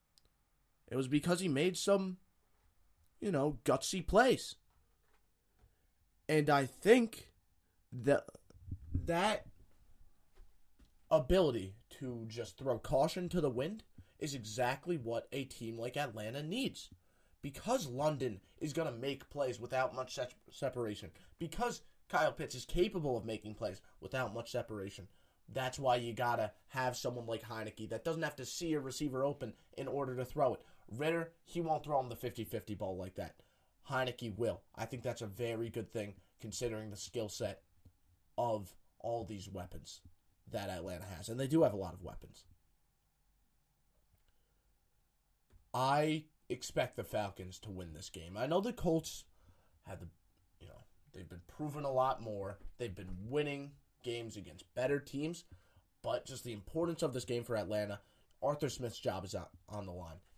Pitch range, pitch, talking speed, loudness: 95-140 Hz, 115 Hz, 155 wpm, -38 LUFS